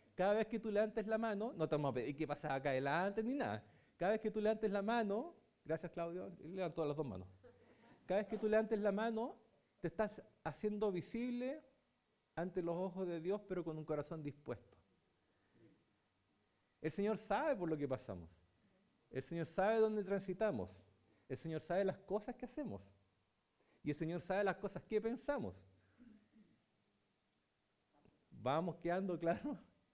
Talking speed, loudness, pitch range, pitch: 170 wpm, -41 LUFS, 140-215 Hz, 175 Hz